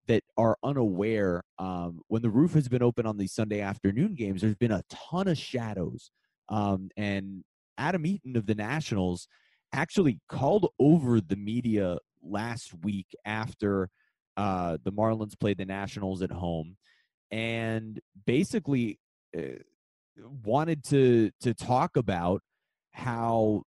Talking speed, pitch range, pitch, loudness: 130 wpm, 95-120 Hz, 110 Hz, -29 LUFS